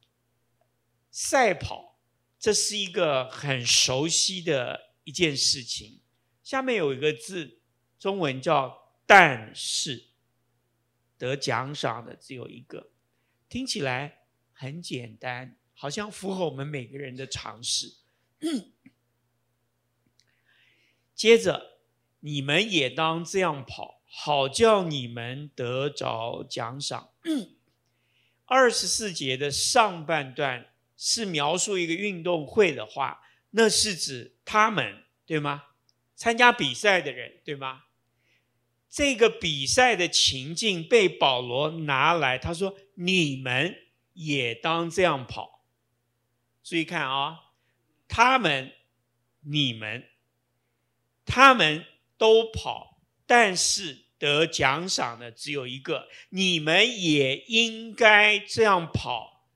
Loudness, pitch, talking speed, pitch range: -24 LUFS, 140 Hz, 155 characters per minute, 120-180 Hz